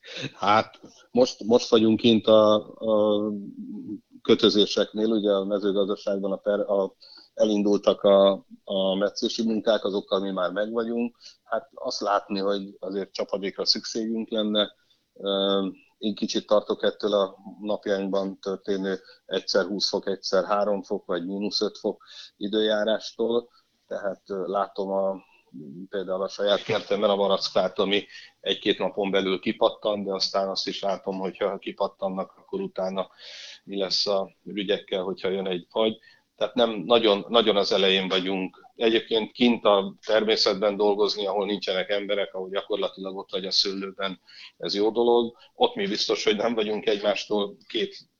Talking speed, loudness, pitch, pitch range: 140 wpm, -25 LUFS, 105 Hz, 95-110 Hz